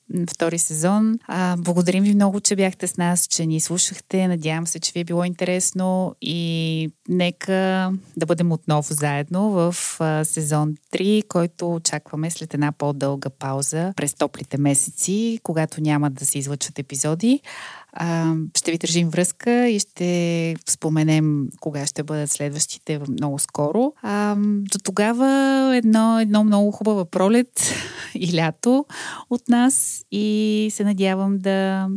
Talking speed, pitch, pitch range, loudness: 135 wpm, 175 Hz, 155-205 Hz, -20 LUFS